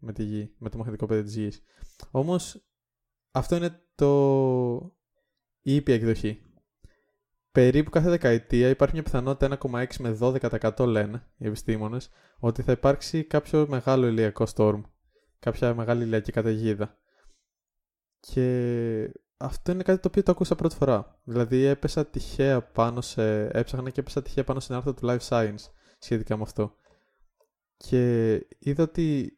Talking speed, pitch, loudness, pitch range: 145 wpm, 125 Hz, -26 LUFS, 115-140 Hz